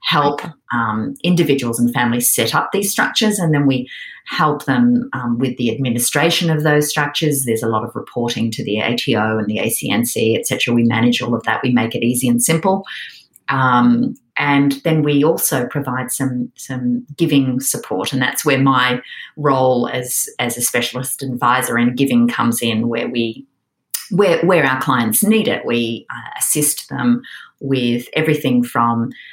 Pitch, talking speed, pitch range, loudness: 130 Hz, 170 wpm, 120-150 Hz, -16 LUFS